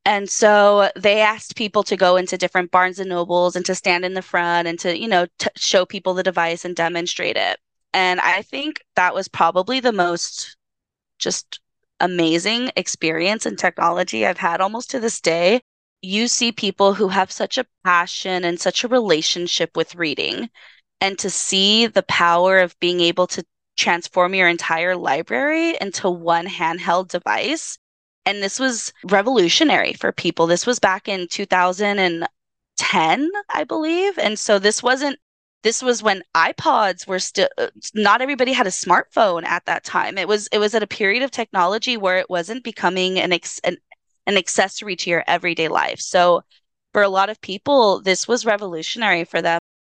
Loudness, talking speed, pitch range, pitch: -19 LUFS, 175 wpm, 175-215 Hz, 190 Hz